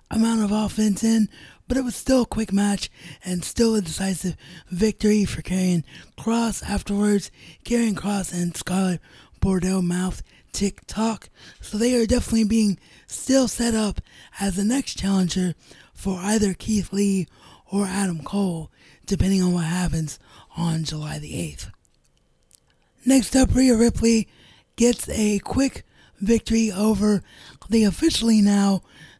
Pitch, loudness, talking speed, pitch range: 200 Hz, -22 LUFS, 140 wpm, 180-225 Hz